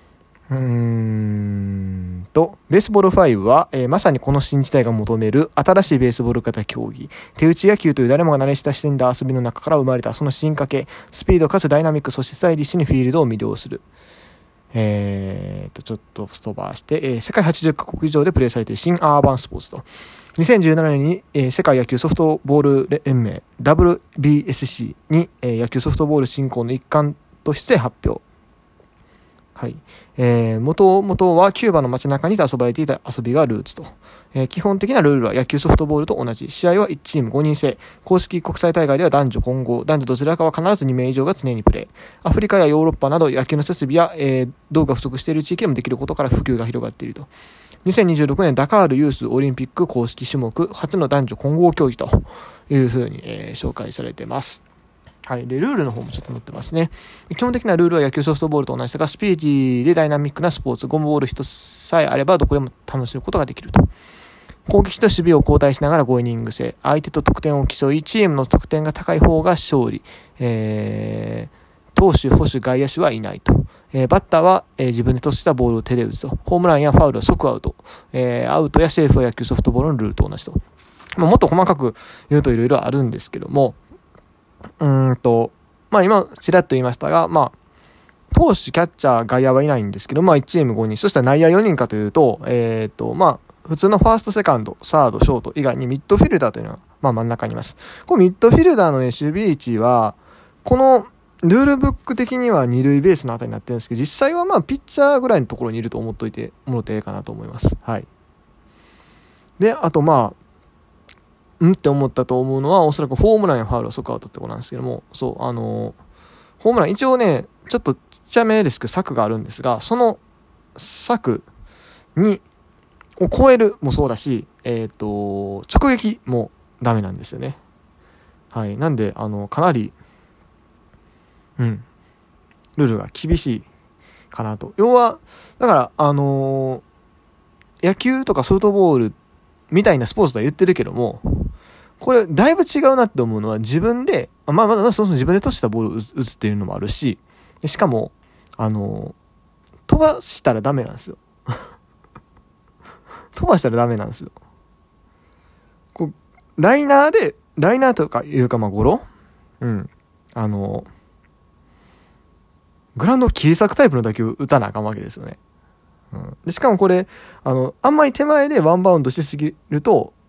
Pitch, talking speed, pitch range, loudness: 135 Hz, 385 characters per minute, 115-170 Hz, -17 LUFS